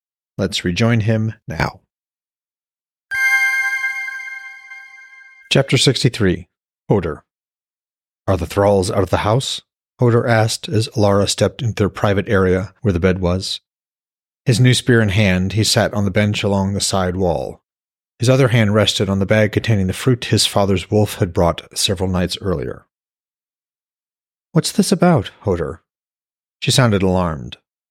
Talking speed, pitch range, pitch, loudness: 145 wpm, 95-130 Hz, 105 Hz, -17 LUFS